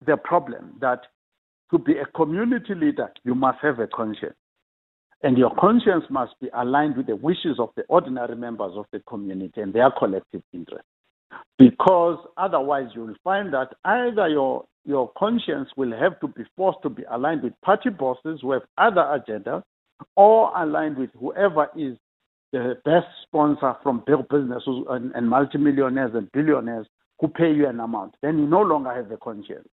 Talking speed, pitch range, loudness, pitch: 175 wpm, 125-170 Hz, -22 LUFS, 145 Hz